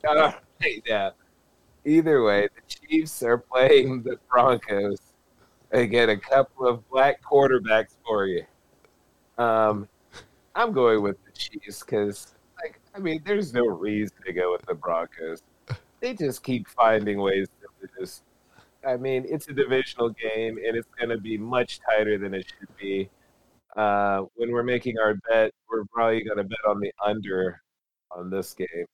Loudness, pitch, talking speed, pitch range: -25 LUFS, 110 Hz, 160 wpm, 100-130 Hz